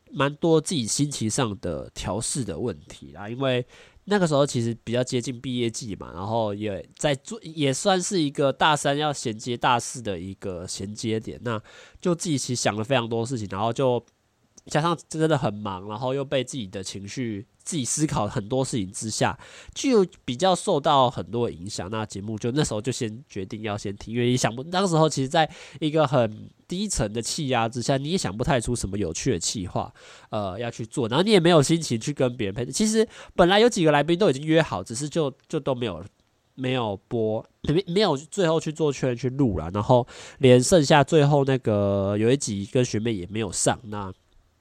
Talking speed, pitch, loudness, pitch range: 300 characters per minute, 125 Hz, -24 LUFS, 110-150 Hz